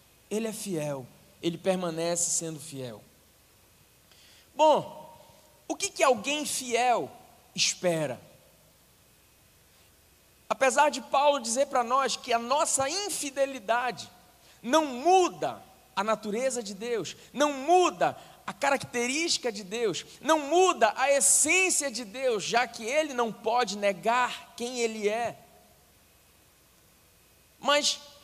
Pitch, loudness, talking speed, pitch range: 250 Hz, -27 LUFS, 110 wpm, 220-290 Hz